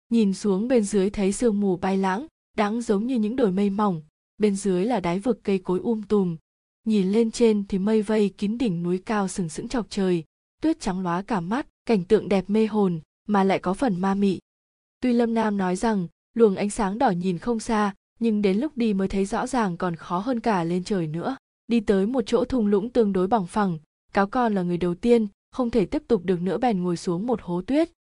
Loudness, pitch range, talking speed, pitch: -24 LUFS, 190-230 Hz, 235 wpm, 210 Hz